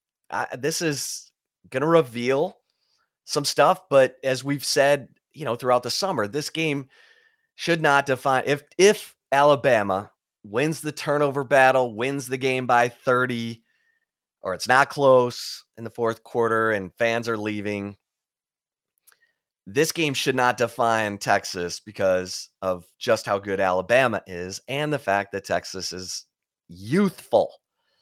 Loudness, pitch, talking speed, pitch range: -23 LUFS, 130 Hz, 140 wpm, 110-145 Hz